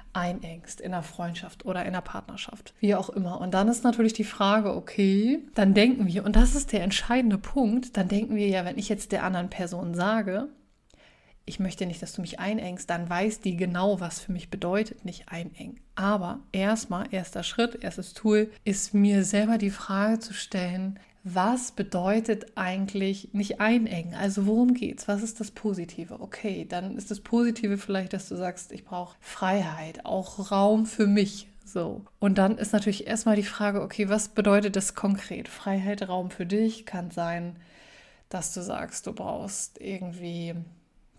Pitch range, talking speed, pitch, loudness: 185-215 Hz, 175 wpm, 200 Hz, -27 LUFS